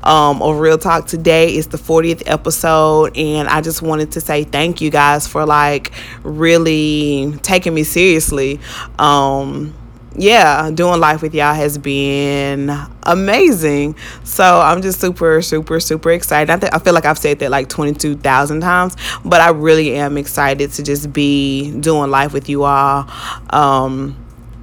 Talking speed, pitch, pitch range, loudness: 155 wpm, 150 Hz, 140-160 Hz, -13 LUFS